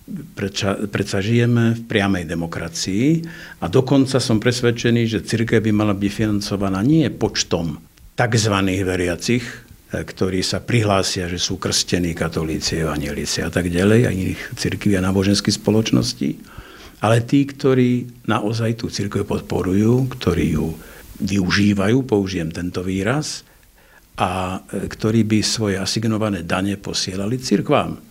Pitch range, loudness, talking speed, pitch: 95-115 Hz, -19 LUFS, 120 wpm, 105 Hz